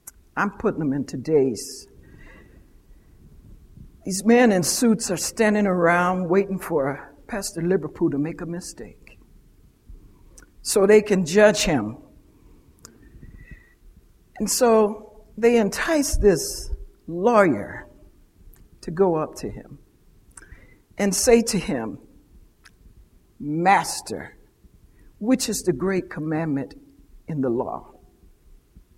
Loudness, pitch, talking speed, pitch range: -21 LUFS, 185 Hz, 100 wpm, 140-210 Hz